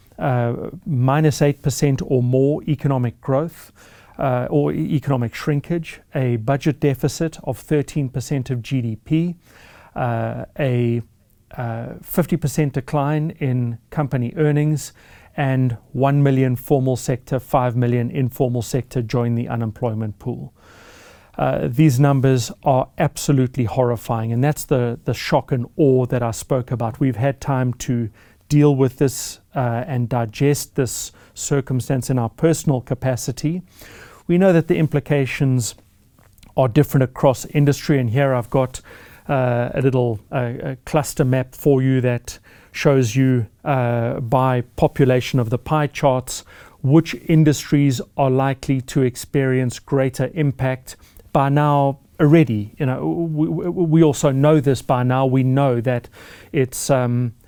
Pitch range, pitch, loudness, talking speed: 120-145 Hz, 130 Hz, -19 LUFS, 135 wpm